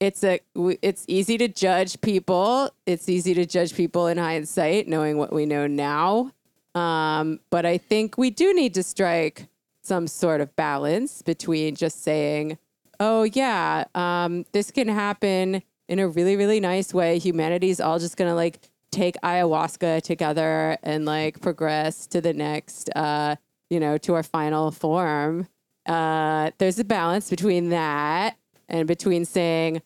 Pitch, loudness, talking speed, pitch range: 175 Hz, -23 LUFS, 155 wpm, 155-190 Hz